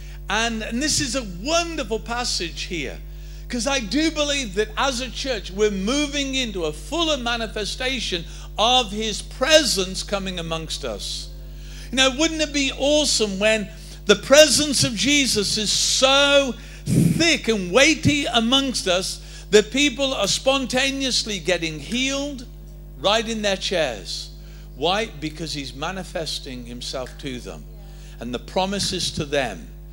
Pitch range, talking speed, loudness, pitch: 160-270 Hz, 135 wpm, -20 LUFS, 215 Hz